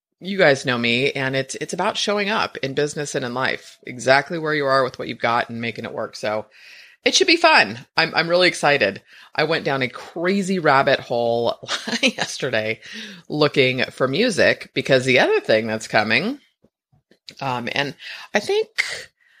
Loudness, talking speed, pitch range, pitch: -20 LUFS, 175 wpm, 130-220 Hz, 150 Hz